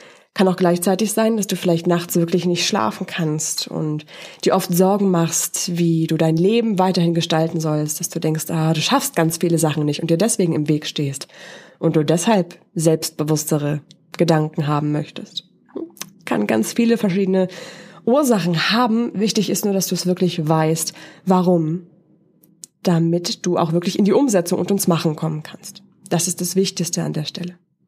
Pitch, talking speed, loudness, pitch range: 175 Hz, 175 wpm, -19 LUFS, 160-190 Hz